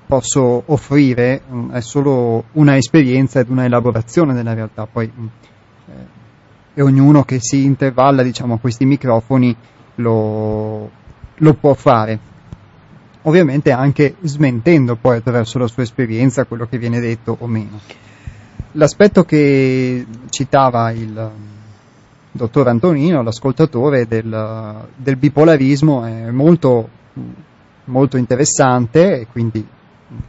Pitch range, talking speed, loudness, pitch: 115-140 Hz, 110 wpm, -14 LUFS, 125 Hz